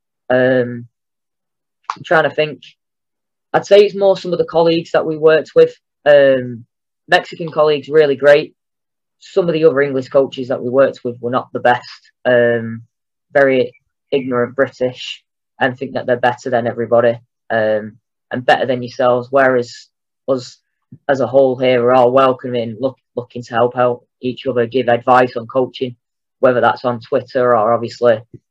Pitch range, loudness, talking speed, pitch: 120-140 Hz, -15 LUFS, 165 wpm, 125 Hz